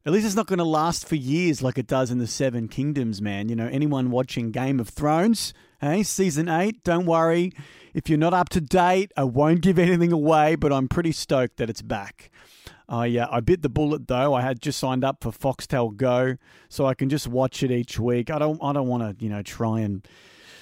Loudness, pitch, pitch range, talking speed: -23 LUFS, 140 Hz, 125-160 Hz, 240 wpm